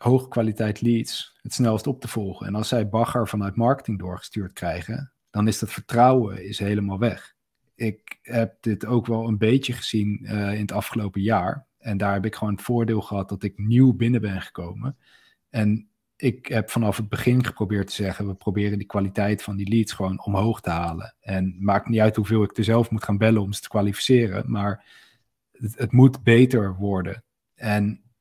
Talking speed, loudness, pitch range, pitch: 195 wpm, -23 LUFS, 100-115 Hz, 110 Hz